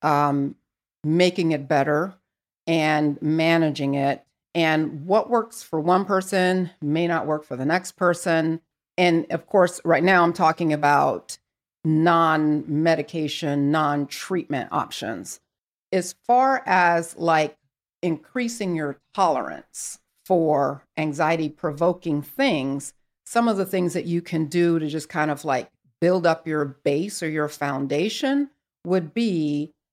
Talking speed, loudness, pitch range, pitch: 130 wpm, -23 LUFS, 150-180 Hz, 160 Hz